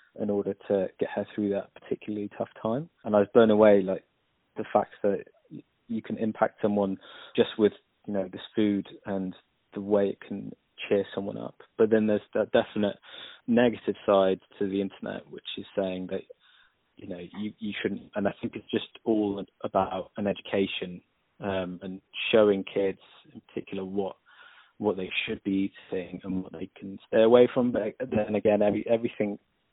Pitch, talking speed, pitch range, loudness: 105 Hz, 180 wpm, 95-110 Hz, -28 LUFS